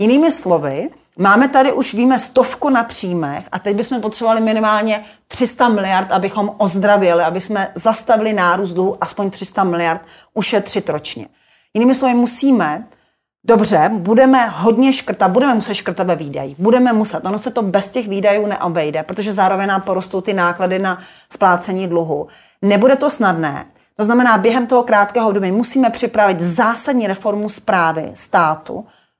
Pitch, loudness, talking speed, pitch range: 210 Hz, -15 LUFS, 150 wpm, 190-235 Hz